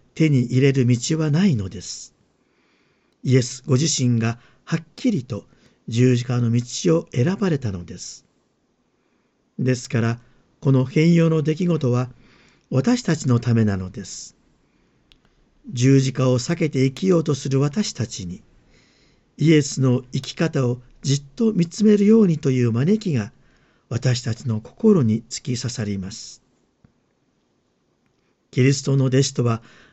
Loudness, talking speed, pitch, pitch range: -20 LUFS, 250 characters per minute, 130 Hz, 120-160 Hz